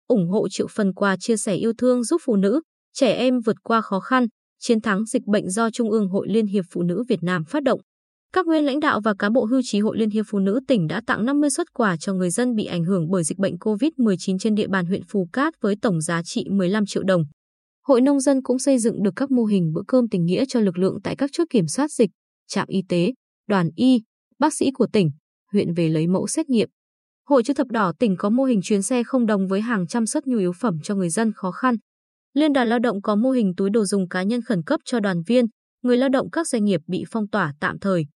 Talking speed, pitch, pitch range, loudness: 260 wpm, 220 Hz, 195-250 Hz, -21 LUFS